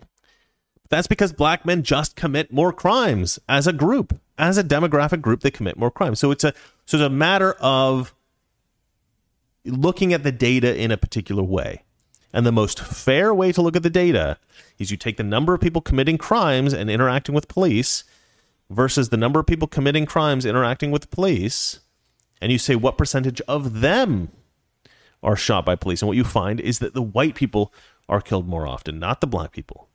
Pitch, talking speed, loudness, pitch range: 135 Hz, 190 wpm, -20 LUFS, 110-155 Hz